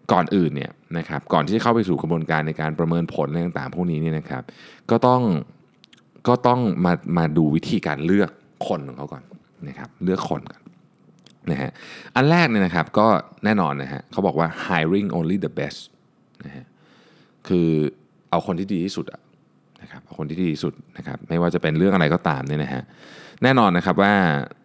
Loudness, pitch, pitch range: -21 LUFS, 85 Hz, 80-95 Hz